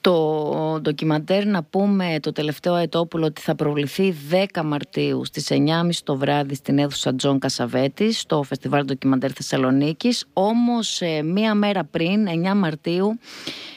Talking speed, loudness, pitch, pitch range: 130 wpm, -21 LUFS, 160 Hz, 145-195 Hz